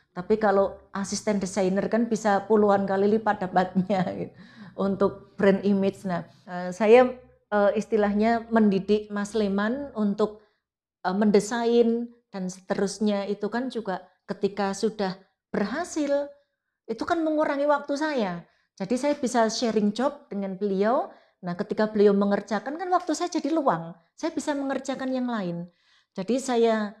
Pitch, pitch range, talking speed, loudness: 210 Hz, 195-240 Hz, 130 wpm, -25 LUFS